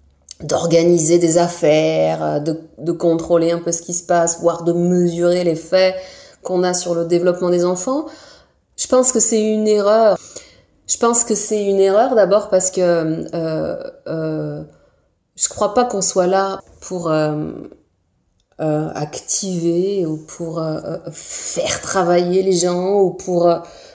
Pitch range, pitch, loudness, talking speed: 165-195 Hz, 175 Hz, -17 LUFS, 155 wpm